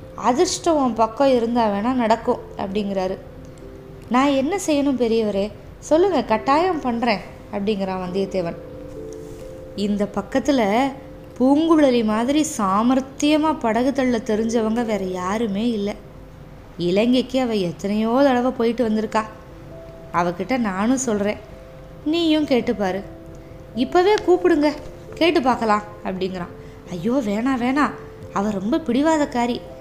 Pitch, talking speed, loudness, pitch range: 235 Hz, 95 wpm, -20 LUFS, 205-275 Hz